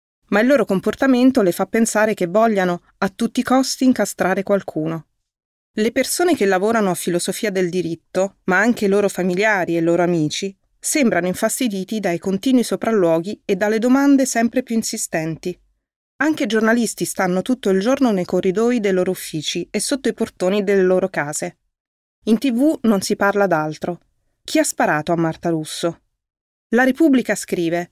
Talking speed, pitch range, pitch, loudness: 165 wpm, 180-230 Hz, 200 Hz, -18 LUFS